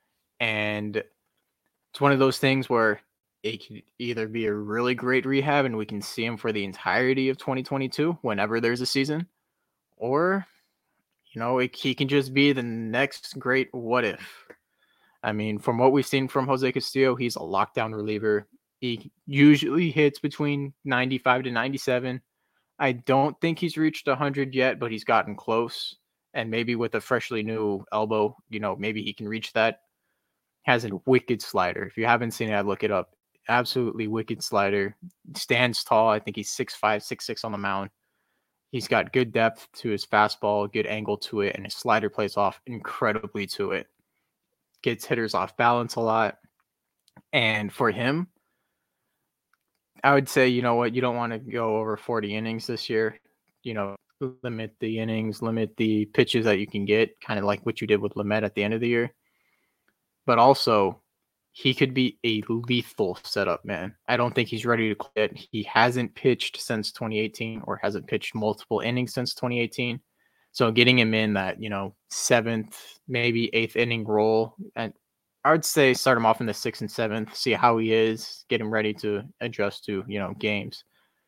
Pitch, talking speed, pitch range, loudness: 115 Hz, 185 wpm, 110-130 Hz, -25 LUFS